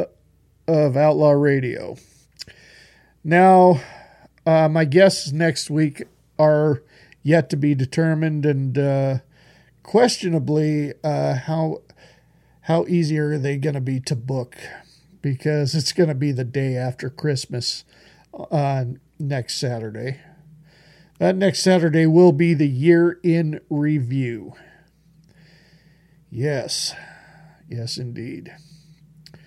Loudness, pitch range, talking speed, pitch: -20 LUFS, 140-165 Hz, 110 wpm, 155 Hz